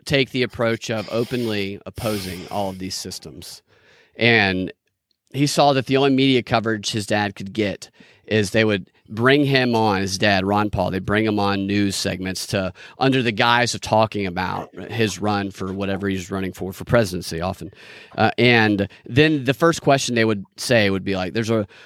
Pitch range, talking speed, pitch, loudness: 95-120 Hz, 190 wpm, 105 Hz, -20 LUFS